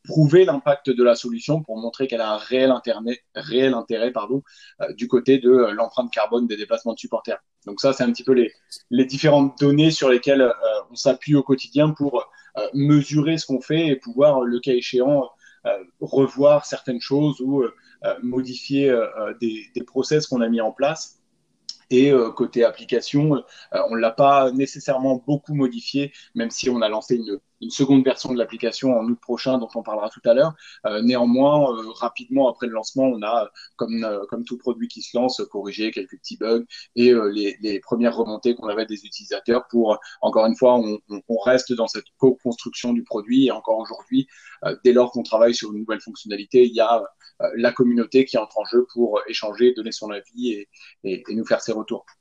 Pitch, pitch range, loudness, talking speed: 125 Hz, 115-140 Hz, -21 LUFS, 205 wpm